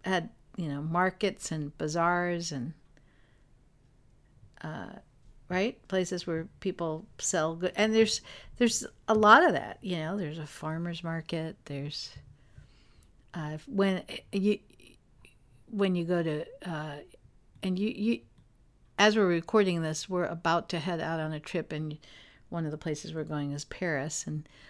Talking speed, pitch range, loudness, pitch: 150 wpm, 150-185 Hz, -30 LUFS, 165 Hz